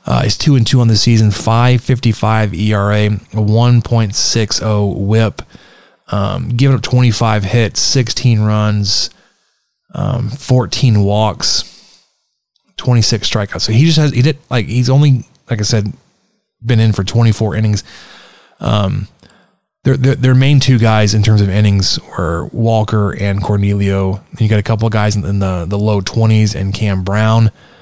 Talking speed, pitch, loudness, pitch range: 160 wpm, 110 Hz, -13 LUFS, 105-120 Hz